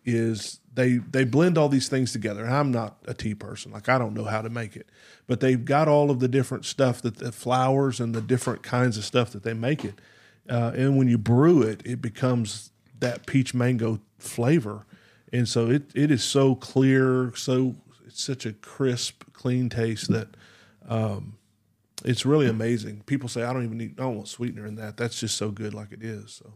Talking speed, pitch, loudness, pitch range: 210 wpm, 120 Hz, -25 LUFS, 110-130 Hz